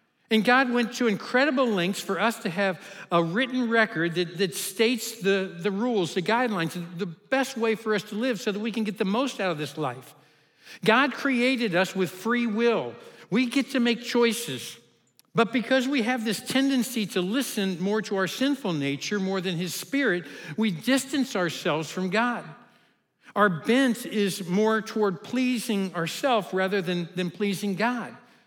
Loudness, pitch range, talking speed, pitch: -26 LUFS, 185-240 Hz, 175 wpm, 215 Hz